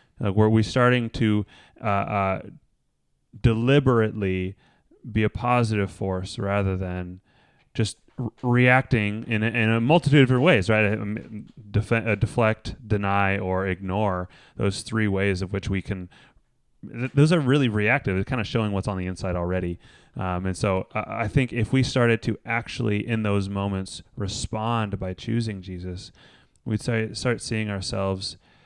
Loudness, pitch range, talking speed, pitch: -24 LUFS, 95-120 Hz, 160 wpm, 110 Hz